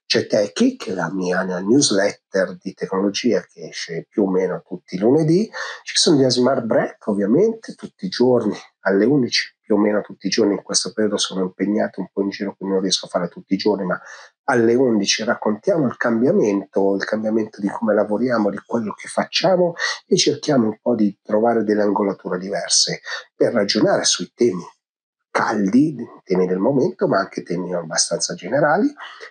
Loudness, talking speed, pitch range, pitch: -19 LUFS, 175 wpm, 95-120 Hz, 105 Hz